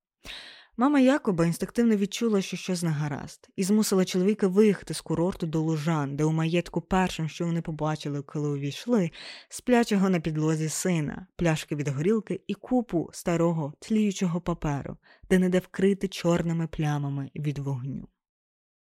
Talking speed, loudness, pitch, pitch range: 145 wpm, -27 LUFS, 175 Hz, 155-195 Hz